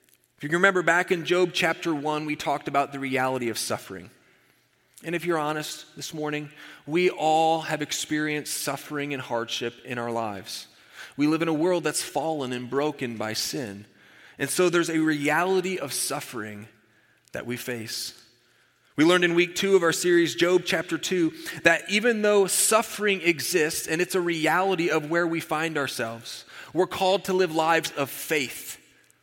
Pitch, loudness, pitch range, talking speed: 155 Hz, -25 LUFS, 140-175 Hz, 175 wpm